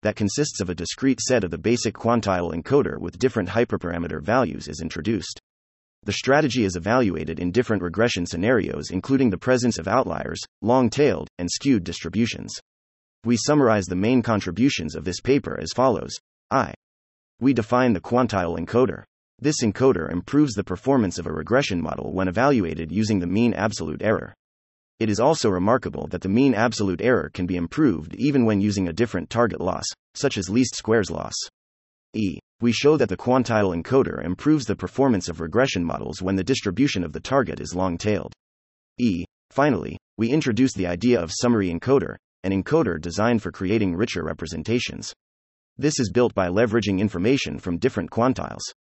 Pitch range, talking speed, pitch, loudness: 85-125 Hz, 170 wpm, 100 Hz, -23 LUFS